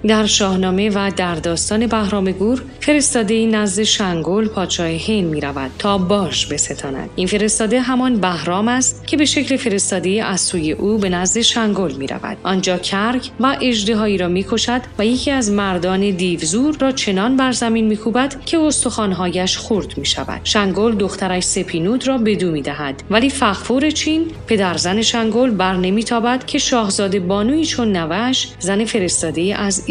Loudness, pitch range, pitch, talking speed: -17 LUFS, 185-240 Hz, 210 Hz, 165 wpm